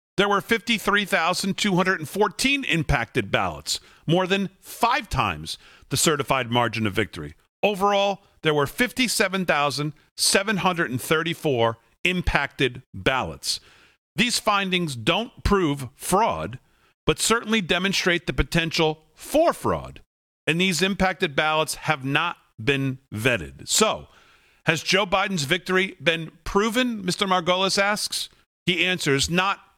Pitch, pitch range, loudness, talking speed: 175 Hz, 140-195 Hz, -23 LUFS, 105 wpm